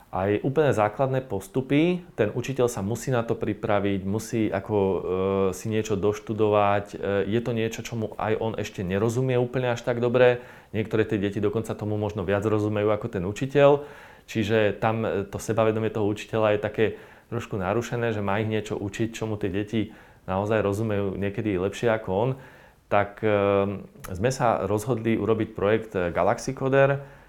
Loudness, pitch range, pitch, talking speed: -25 LUFS, 100-120 Hz, 110 Hz, 165 wpm